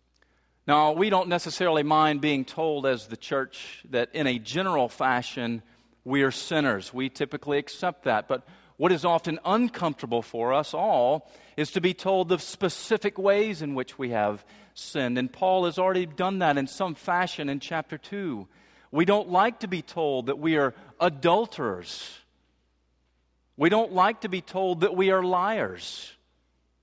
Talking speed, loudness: 165 wpm, -26 LUFS